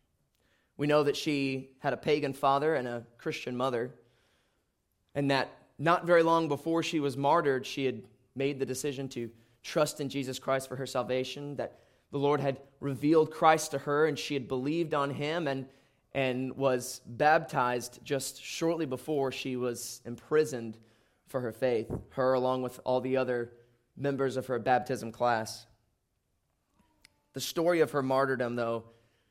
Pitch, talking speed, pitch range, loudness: 135 Hz, 160 wpm, 125-145 Hz, -31 LUFS